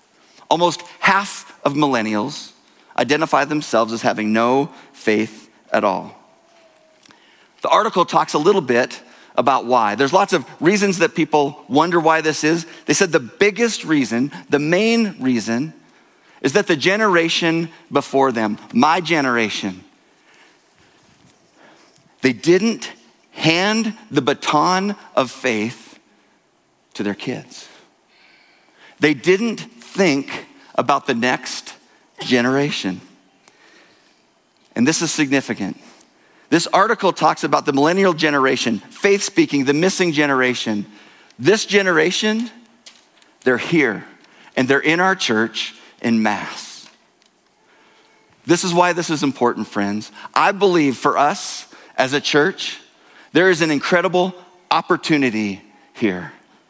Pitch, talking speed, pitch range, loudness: 160 Hz, 115 wpm, 135-190 Hz, -18 LUFS